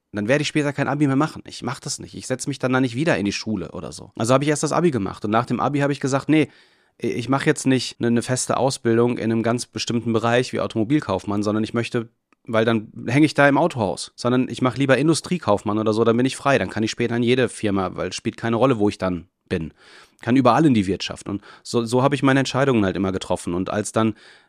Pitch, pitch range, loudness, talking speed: 120 Hz, 110-135 Hz, -21 LUFS, 260 wpm